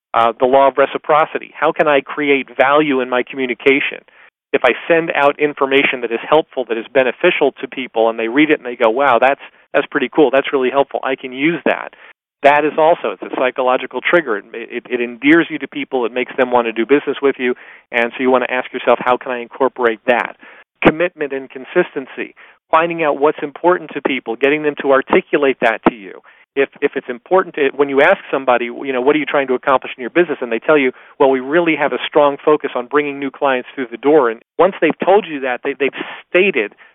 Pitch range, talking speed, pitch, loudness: 125-150 Hz, 230 wpm, 140 Hz, -15 LUFS